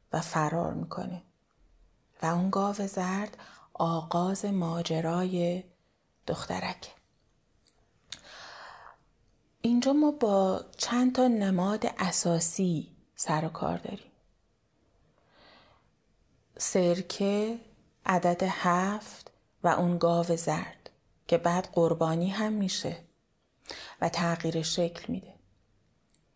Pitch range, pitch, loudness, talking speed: 170-200 Hz, 180 Hz, -29 LUFS, 85 wpm